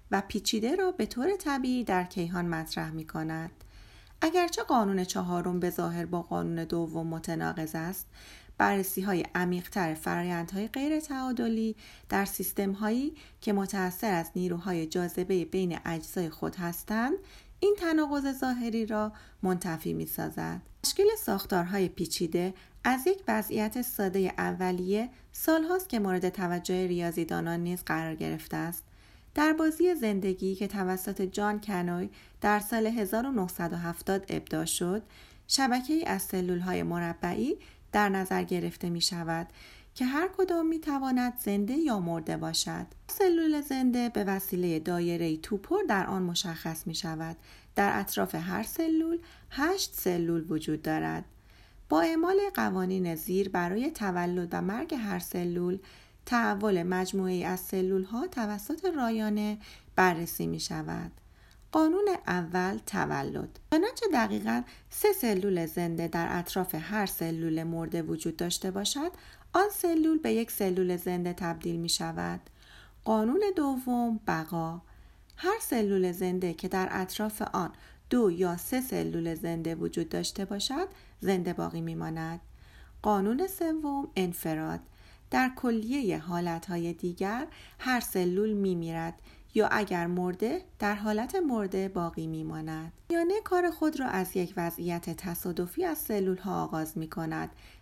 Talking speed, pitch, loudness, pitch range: 130 wpm, 190 Hz, -31 LUFS, 170-235 Hz